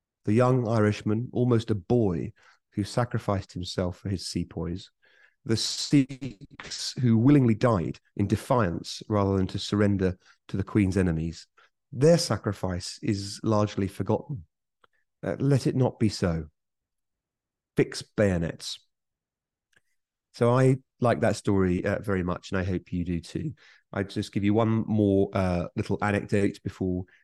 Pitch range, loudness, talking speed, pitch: 95-120 Hz, -27 LUFS, 140 wpm, 105 Hz